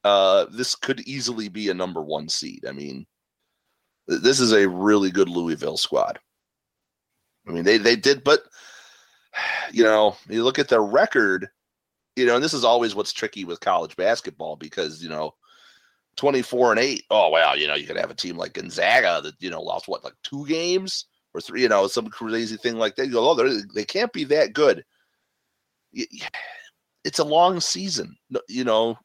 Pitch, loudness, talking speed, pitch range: 115 Hz, -22 LUFS, 190 wpm, 100-145 Hz